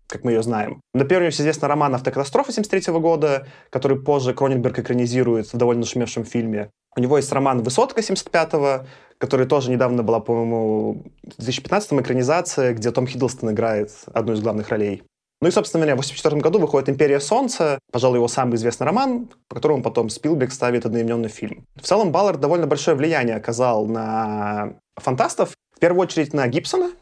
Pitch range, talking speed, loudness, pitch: 115-150 Hz, 175 wpm, -20 LUFS, 130 Hz